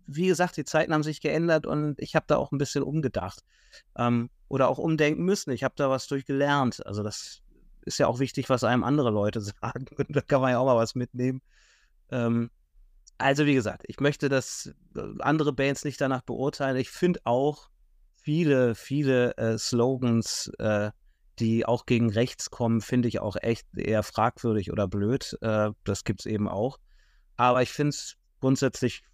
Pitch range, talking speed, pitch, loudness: 115-140 Hz, 185 wpm, 130 Hz, -27 LUFS